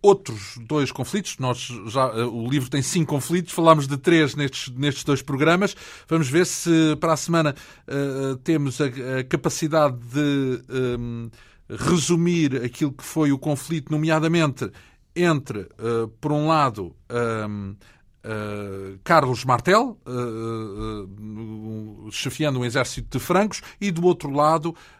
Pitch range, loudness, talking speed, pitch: 115-160 Hz, -22 LUFS, 135 wpm, 140 Hz